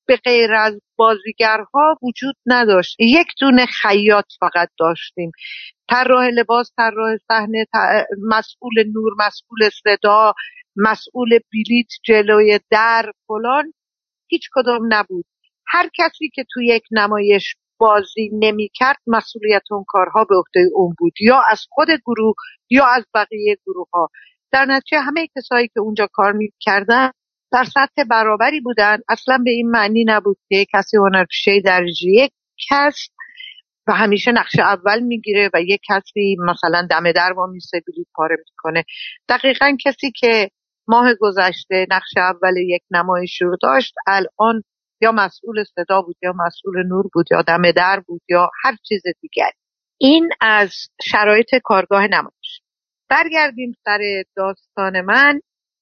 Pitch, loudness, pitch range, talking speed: 215 Hz, -15 LUFS, 195-245 Hz, 135 wpm